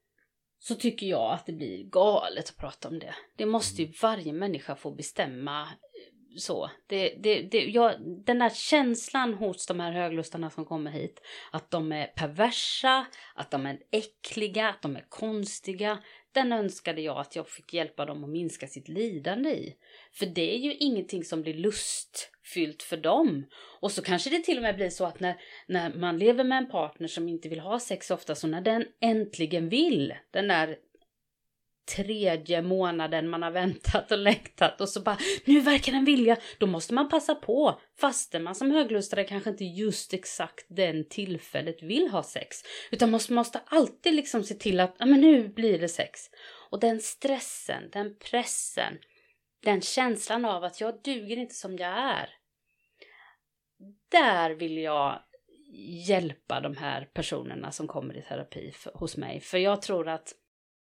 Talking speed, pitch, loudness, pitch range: 170 wpm, 200 Hz, -28 LUFS, 170-235 Hz